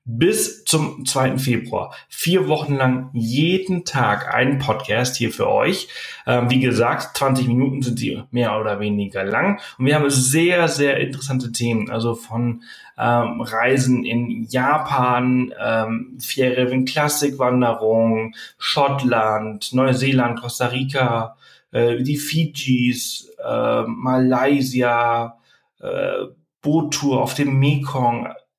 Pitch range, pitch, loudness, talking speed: 120-140 Hz, 125 Hz, -19 LUFS, 120 wpm